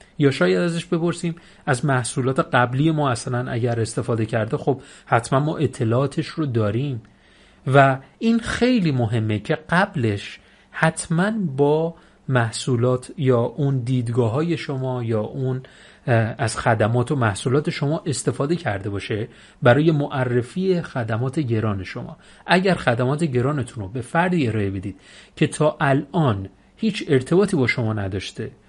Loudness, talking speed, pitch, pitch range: -21 LUFS, 130 wpm, 135 Hz, 115-155 Hz